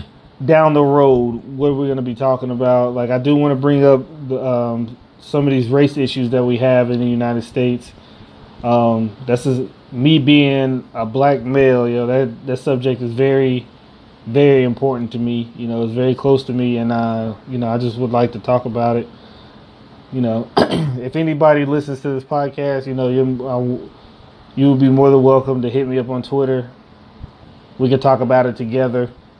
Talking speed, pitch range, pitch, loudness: 200 wpm, 120-135 Hz, 130 Hz, -16 LUFS